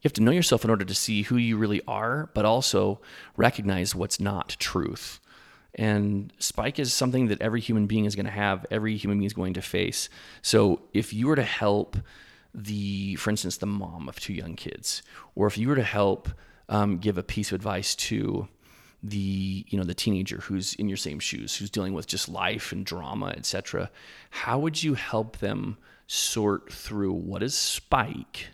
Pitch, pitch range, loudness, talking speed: 105 Hz, 95-110 Hz, -27 LUFS, 200 wpm